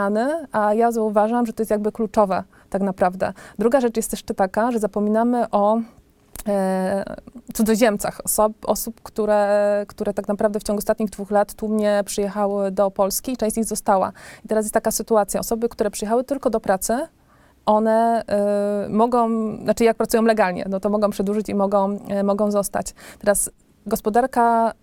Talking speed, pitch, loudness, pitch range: 165 wpm, 215 Hz, -21 LUFS, 205-225 Hz